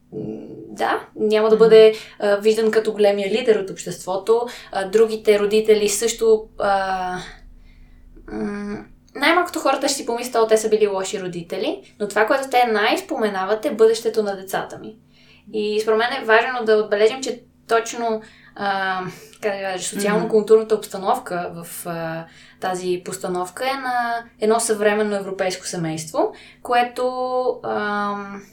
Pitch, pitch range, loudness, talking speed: 215 Hz, 190-225 Hz, -20 LUFS, 135 wpm